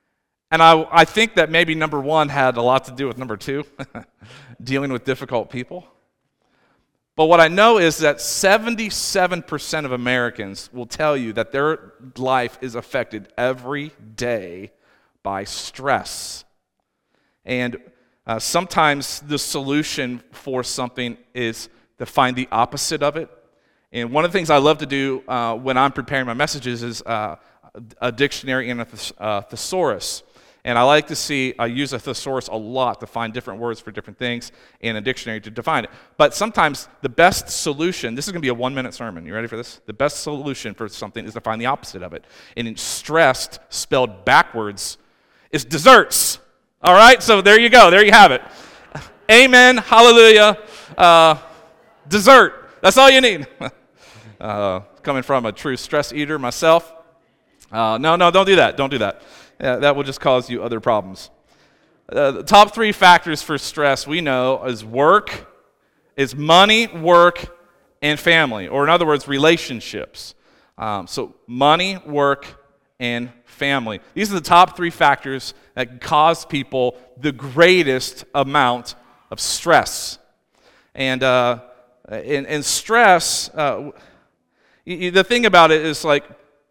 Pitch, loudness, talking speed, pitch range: 140 Hz, -16 LUFS, 165 wpm, 120-160 Hz